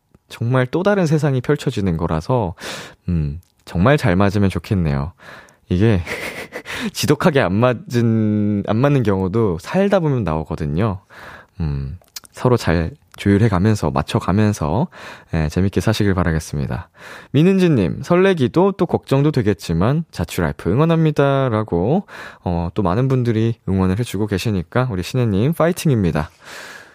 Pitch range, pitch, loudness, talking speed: 90-135 Hz, 105 Hz, -18 LUFS, 295 characters per minute